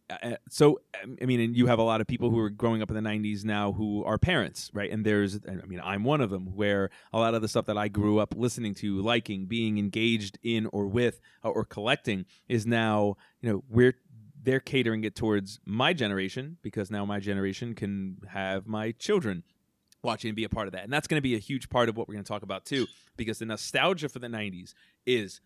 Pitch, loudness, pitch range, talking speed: 110 Hz, -29 LUFS, 100-120 Hz, 240 wpm